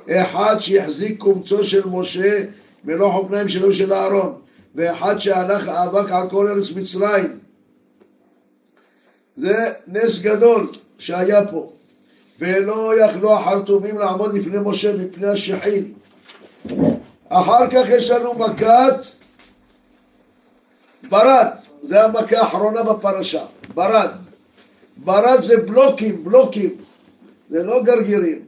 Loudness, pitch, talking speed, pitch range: -17 LUFS, 205 Hz, 100 wpm, 195-230 Hz